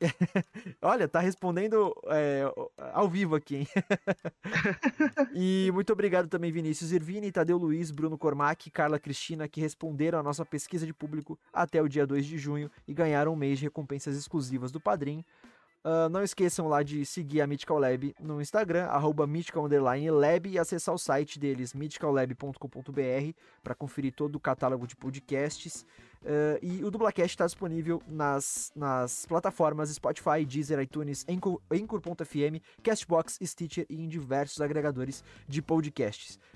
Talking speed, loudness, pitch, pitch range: 150 wpm, -31 LUFS, 155 Hz, 145-175 Hz